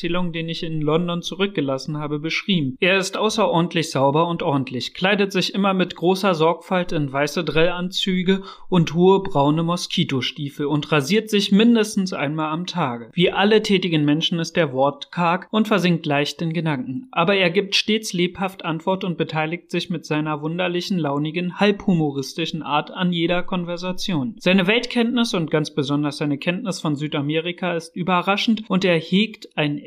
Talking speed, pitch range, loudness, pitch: 160 wpm, 155-190 Hz, -21 LUFS, 175 Hz